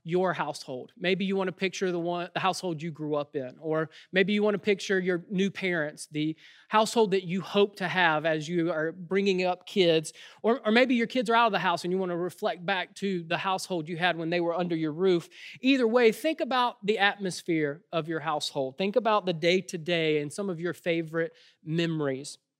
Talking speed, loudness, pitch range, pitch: 220 wpm, -28 LUFS, 165-200 Hz, 180 Hz